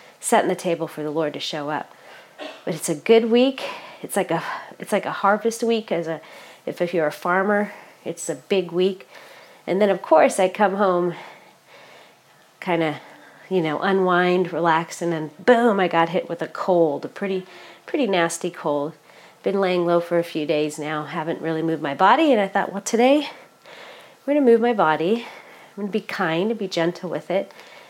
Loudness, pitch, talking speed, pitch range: -21 LUFS, 180 Hz, 200 wpm, 165-205 Hz